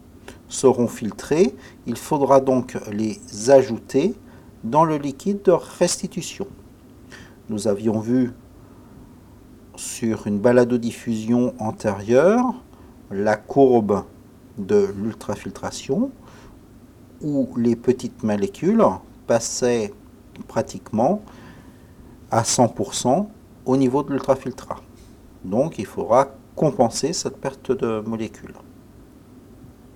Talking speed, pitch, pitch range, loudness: 90 wpm, 125 Hz, 110-135 Hz, -21 LUFS